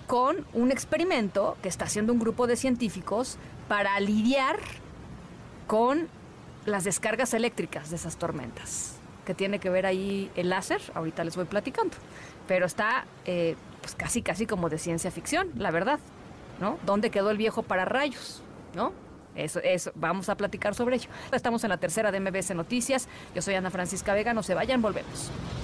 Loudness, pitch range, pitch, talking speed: -29 LUFS, 180-235 Hz, 200 Hz, 170 wpm